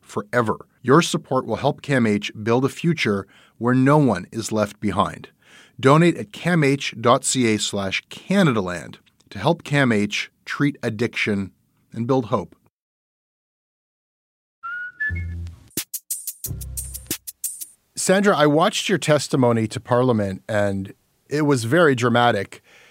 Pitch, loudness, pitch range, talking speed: 125 Hz, -21 LUFS, 105-150 Hz, 100 wpm